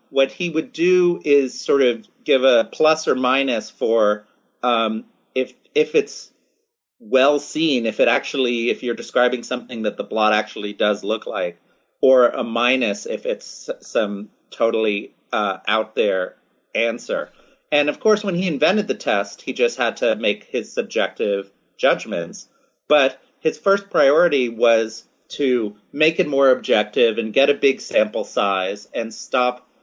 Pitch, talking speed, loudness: 135 Hz, 155 wpm, -20 LUFS